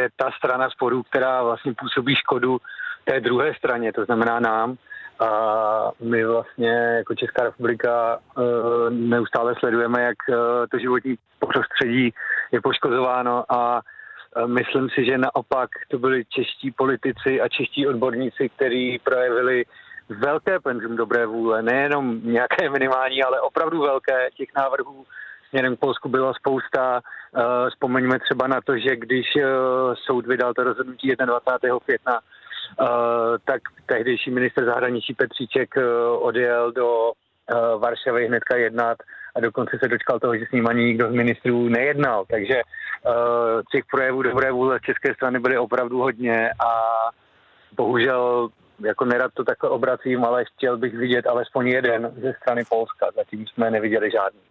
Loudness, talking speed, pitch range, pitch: -22 LUFS, 140 wpm, 115-130 Hz, 125 Hz